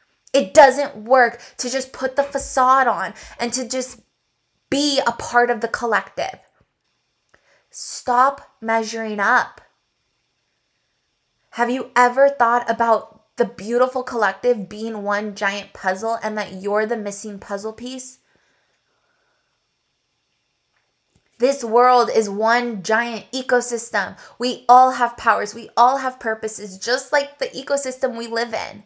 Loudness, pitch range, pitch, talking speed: -19 LUFS, 220-255 Hz, 240 Hz, 125 wpm